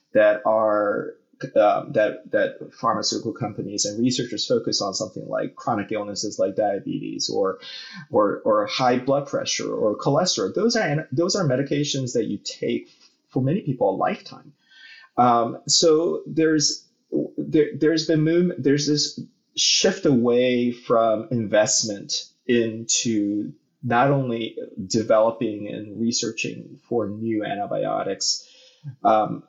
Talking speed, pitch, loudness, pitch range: 120 wpm, 125 Hz, -22 LUFS, 110-155 Hz